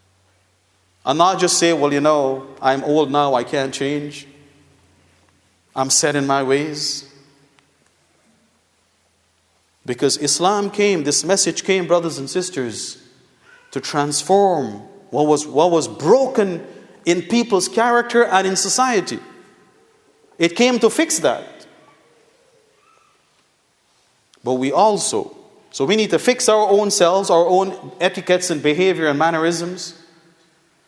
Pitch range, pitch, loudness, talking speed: 140-195 Hz, 165 Hz, -17 LUFS, 120 wpm